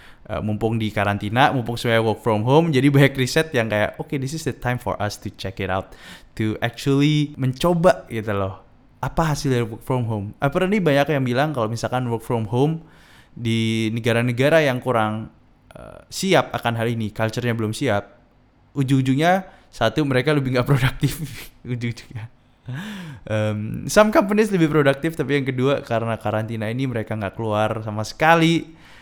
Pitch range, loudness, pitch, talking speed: 110-140 Hz, -21 LUFS, 120 Hz, 170 wpm